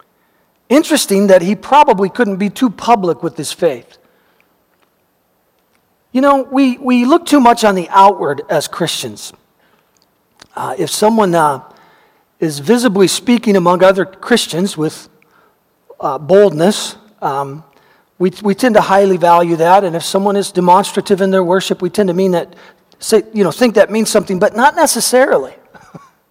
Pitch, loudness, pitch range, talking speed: 200 Hz, -12 LUFS, 185-240 Hz, 155 wpm